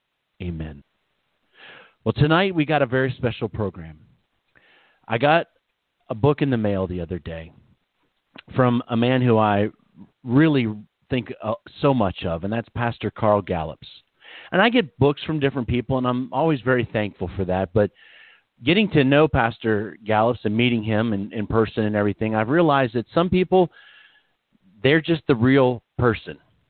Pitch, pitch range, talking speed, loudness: 120 Hz, 105-140 Hz, 160 wpm, -21 LUFS